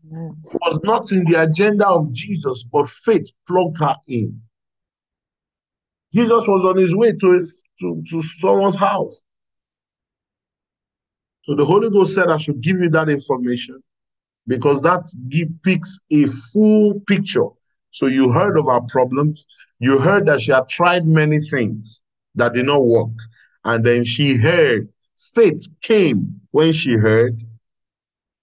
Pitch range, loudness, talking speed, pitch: 125-185 Hz, -17 LUFS, 145 wpm, 150 Hz